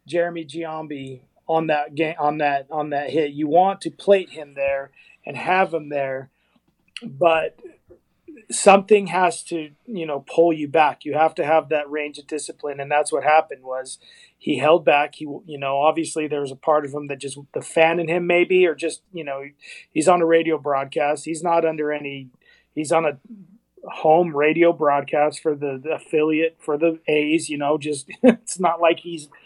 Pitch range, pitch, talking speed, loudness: 145-165 Hz, 155 Hz, 195 wpm, -21 LUFS